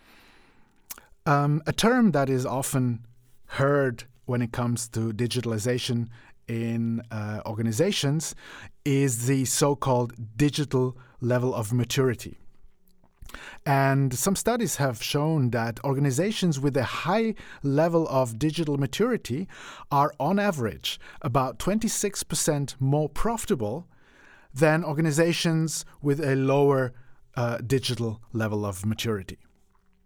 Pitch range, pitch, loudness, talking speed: 120-150 Hz, 135 Hz, -26 LUFS, 110 wpm